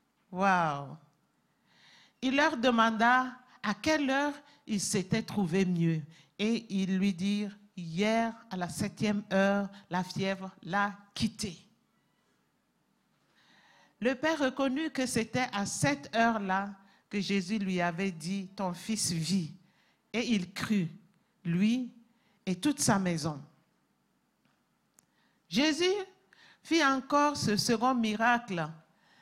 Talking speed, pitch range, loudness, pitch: 110 wpm, 190-235 Hz, -31 LUFS, 205 Hz